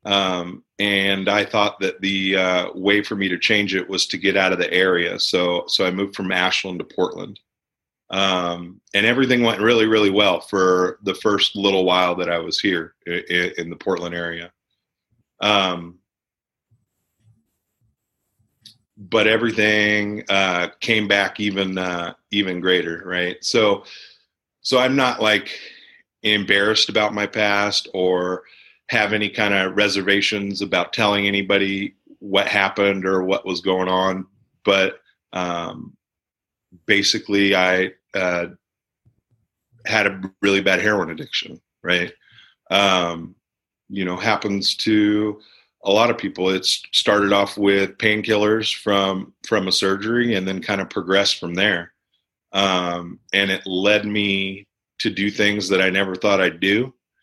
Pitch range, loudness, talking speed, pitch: 95-105 Hz, -19 LUFS, 145 wpm, 100 Hz